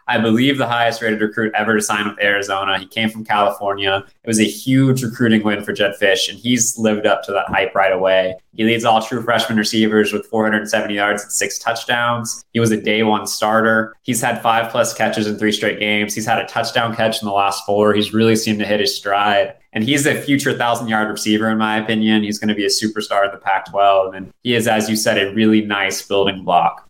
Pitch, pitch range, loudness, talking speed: 110 Hz, 105-115 Hz, -17 LUFS, 240 wpm